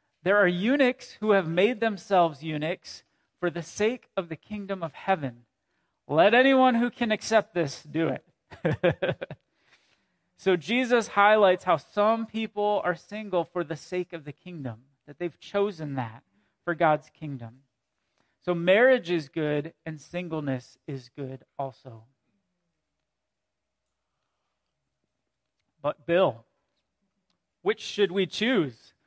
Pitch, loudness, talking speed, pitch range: 175 Hz, -26 LUFS, 125 wpm, 150-205 Hz